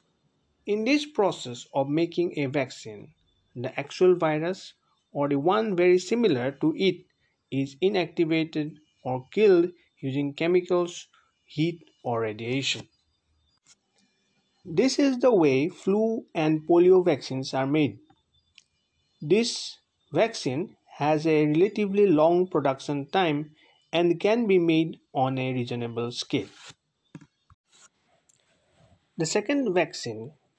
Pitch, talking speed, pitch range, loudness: 155 Hz, 110 wpm, 135-180 Hz, -25 LUFS